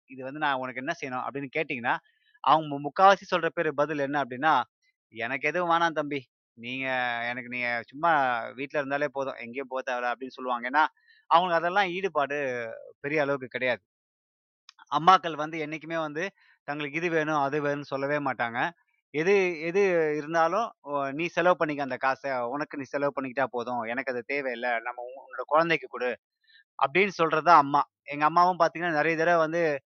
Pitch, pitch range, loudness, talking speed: 145 Hz, 130-165 Hz, -27 LUFS, 155 wpm